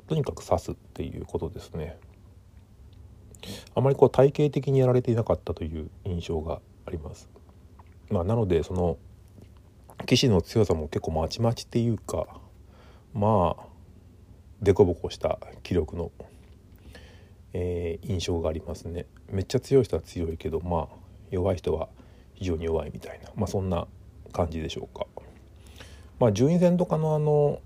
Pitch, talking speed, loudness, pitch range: 95 Hz, 295 characters per minute, -27 LUFS, 85-105 Hz